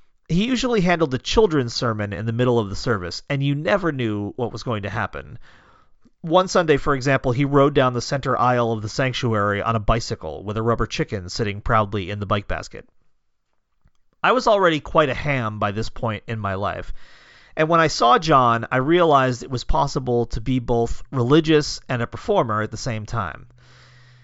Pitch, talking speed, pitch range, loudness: 120 Hz, 200 wpm, 110-140 Hz, -21 LUFS